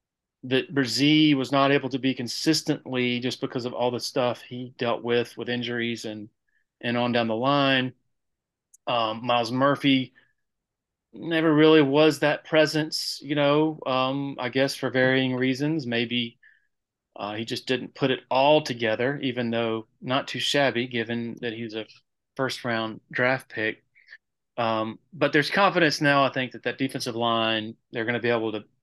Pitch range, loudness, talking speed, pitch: 120-140 Hz, -24 LUFS, 170 wpm, 125 Hz